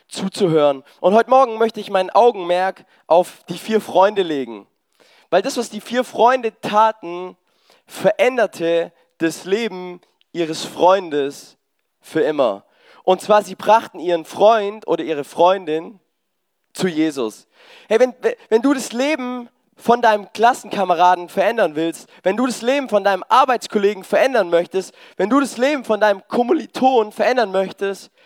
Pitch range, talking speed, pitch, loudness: 175-235 Hz, 140 wpm, 200 Hz, -18 LUFS